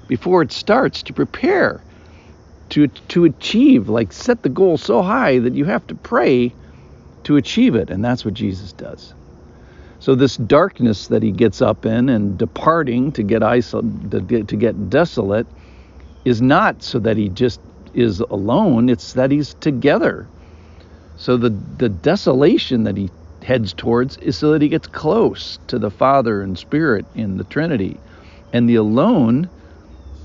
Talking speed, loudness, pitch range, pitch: 160 wpm, -17 LUFS, 95-130 Hz, 115 Hz